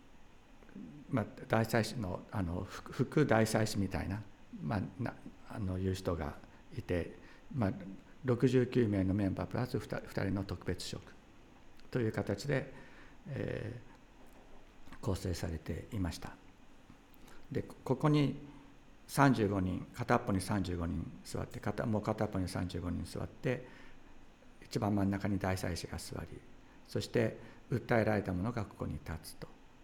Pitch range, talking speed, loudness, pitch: 95-120 Hz, 215 characters per minute, -36 LUFS, 100 Hz